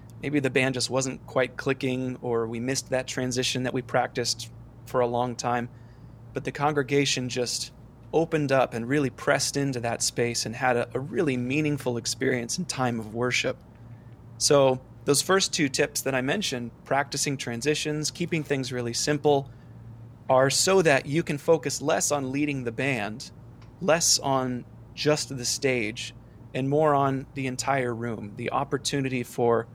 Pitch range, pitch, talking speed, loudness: 120-140 Hz, 130 Hz, 165 wpm, -26 LUFS